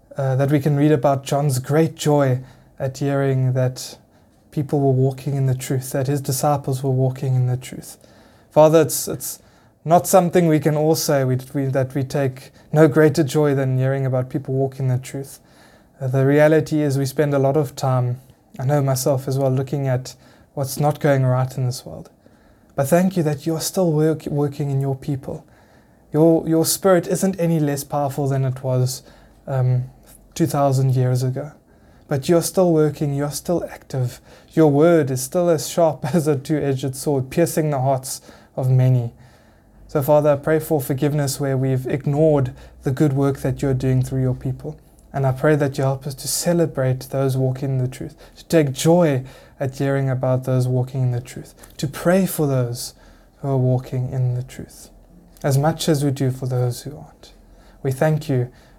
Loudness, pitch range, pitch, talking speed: -20 LUFS, 130-155 Hz, 140 Hz, 190 wpm